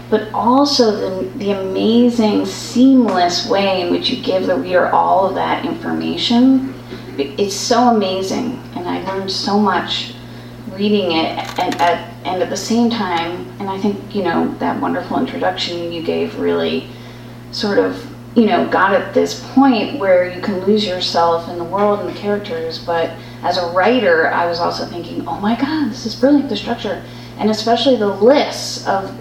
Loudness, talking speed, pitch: -16 LUFS, 180 wpm, 185 Hz